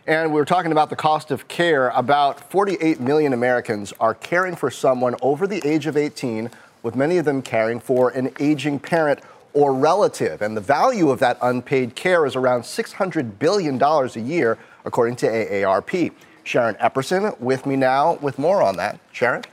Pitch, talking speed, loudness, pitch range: 140 Hz, 180 wpm, -20 LUFS, 125-155 Hz